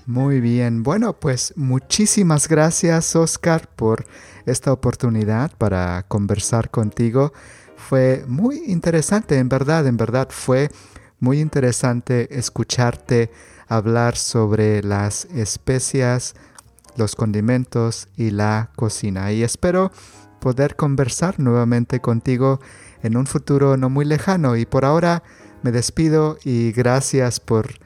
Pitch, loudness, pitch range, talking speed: 125 Hz, -19 LUFS, 115-140 Hz, 115 wpm